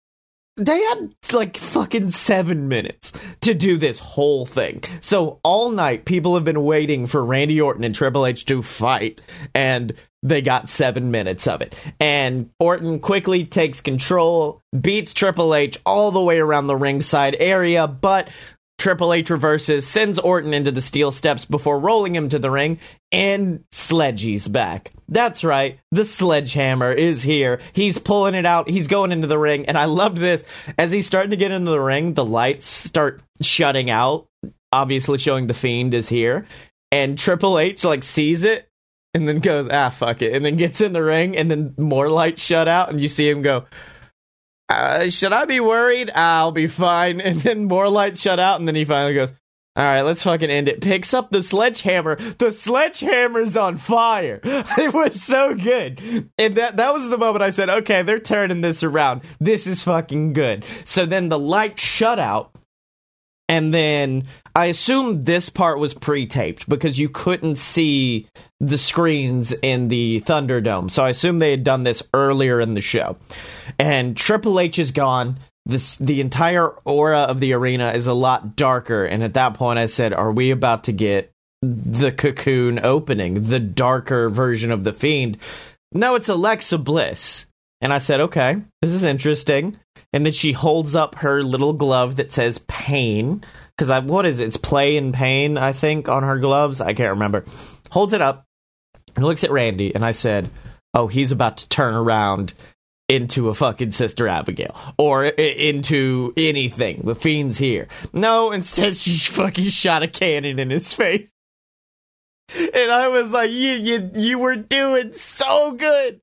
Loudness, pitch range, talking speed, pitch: -19 LUFS, 130-185 Hz, 180 wpm, 150 Hz